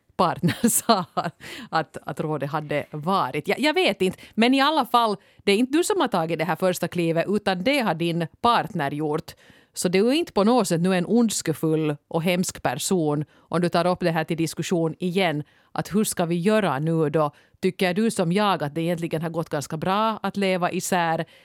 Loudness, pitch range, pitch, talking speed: -23 LUFS, 160-205 Hz, 175 Hz, 215 wpm